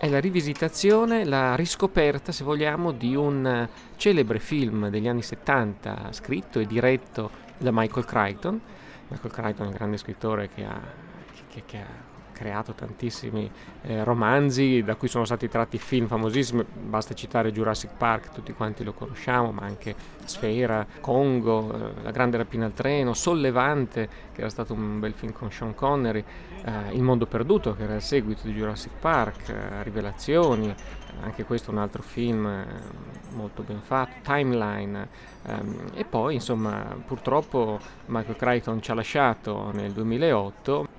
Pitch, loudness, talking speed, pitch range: 115 Hz, -26 LUFS, 160 wpm, 110-130 Hz